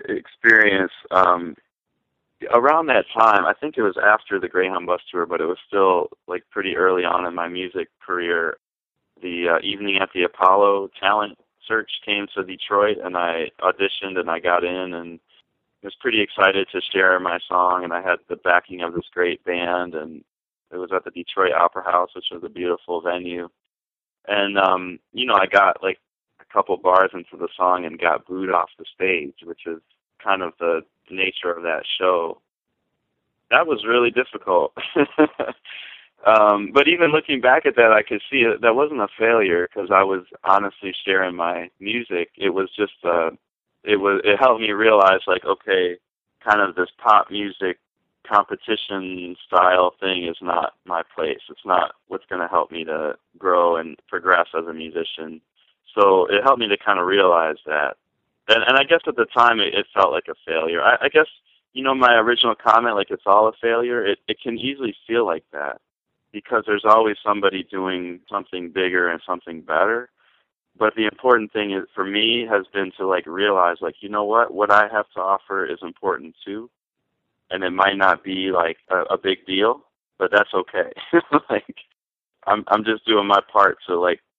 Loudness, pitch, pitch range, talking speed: -19 LUFS, 95 Hz, 90-115 Hz, 185 wpm